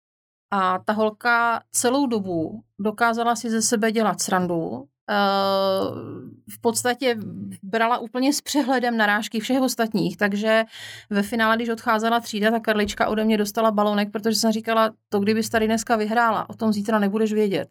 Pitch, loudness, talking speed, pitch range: 220 Hz, -22 LUFS, 155 wpm, 205-230 Hz